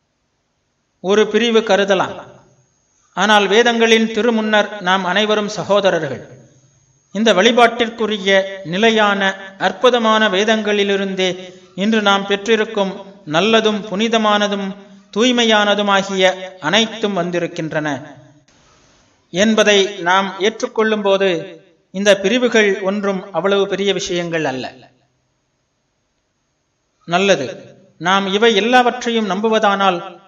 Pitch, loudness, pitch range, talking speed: 195 Hz, -15 LUFS, 185-215 Hz, 75 wpm